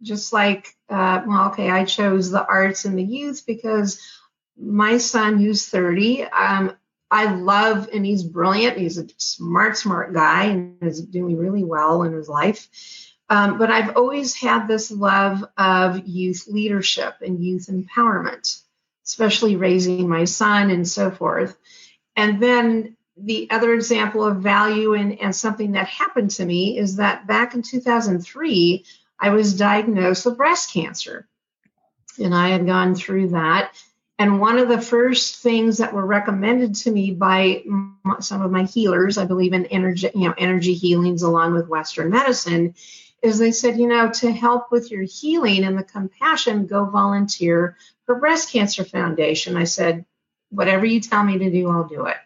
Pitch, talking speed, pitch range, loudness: 200 Hz, 165 wpm, 185-225 Hz, -19 LUFS